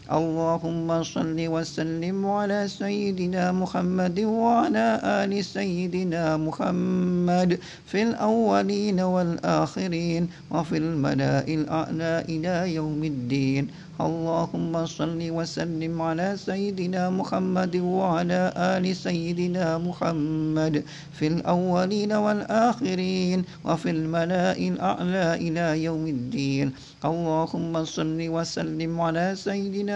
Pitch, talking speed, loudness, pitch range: 170 Hz, 85 wpm, -25 LUFS, 160-185 Hz